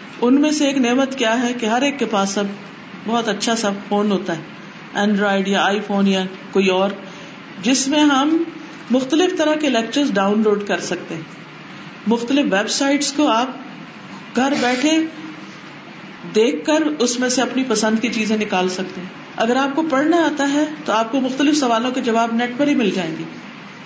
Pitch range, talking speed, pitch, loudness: 200-275 Hz, 190 wpm, 230 Hz, -18 LUFS